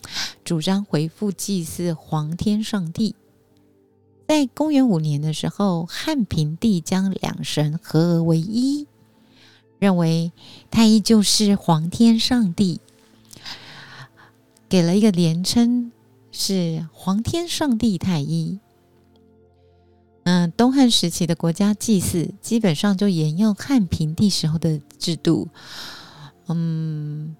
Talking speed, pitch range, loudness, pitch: 170 characters per minute, 160-215 Hz, -20 LUFS, 180 Hz